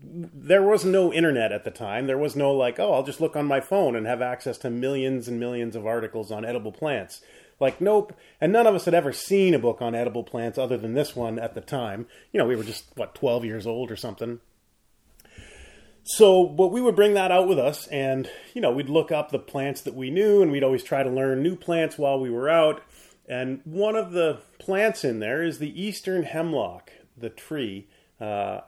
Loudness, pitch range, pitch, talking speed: -24 LUFS, 120-175 Hz, 140 Hz, 225 wpm